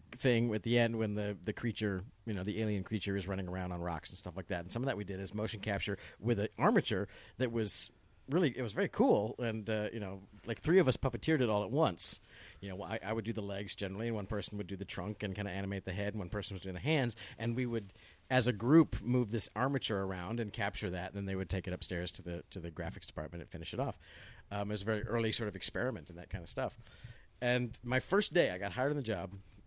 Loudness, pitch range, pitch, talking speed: -36 LUFS, 95-115 Hz, 105 Hz, 275 wpm